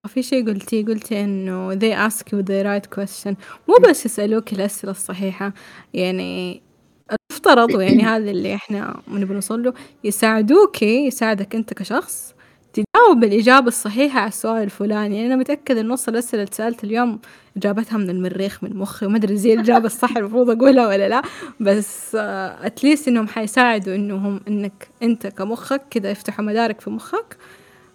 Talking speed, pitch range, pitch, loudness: 150 wpm, 200-240 Hz, 220 Hz, -18 LUFS